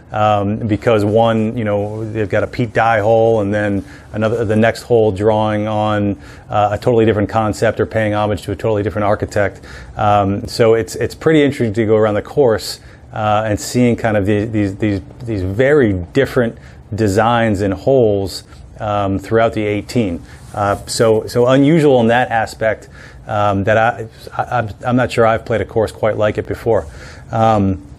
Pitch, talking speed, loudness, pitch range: 110 Hz, 185 wpm, -15 LUFS, 105-115 Hz